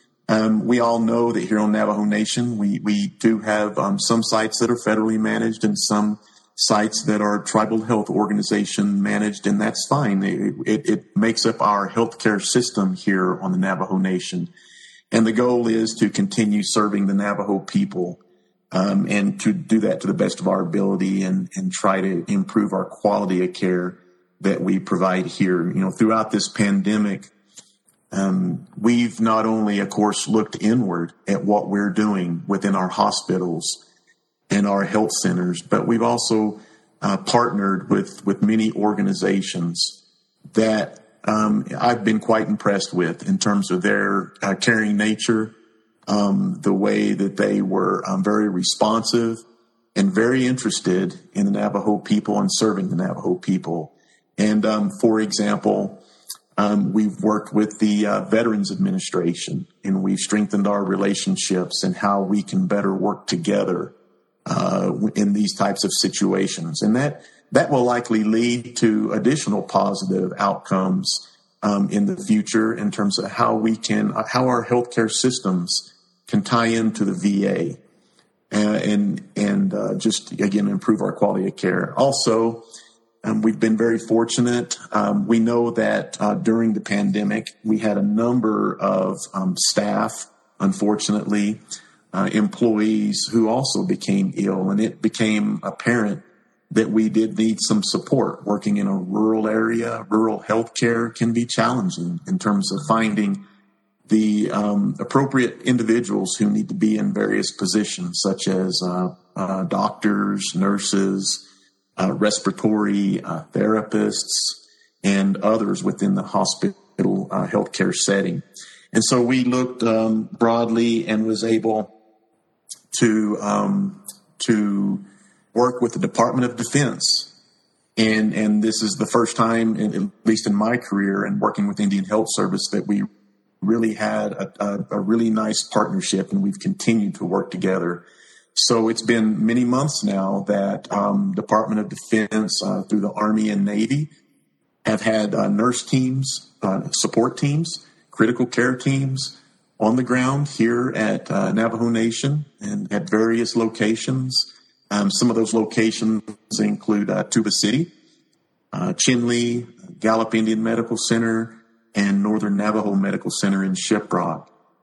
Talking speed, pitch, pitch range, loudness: 150 wpm, 110 Hz, 105-120 Hz, -21 LUFS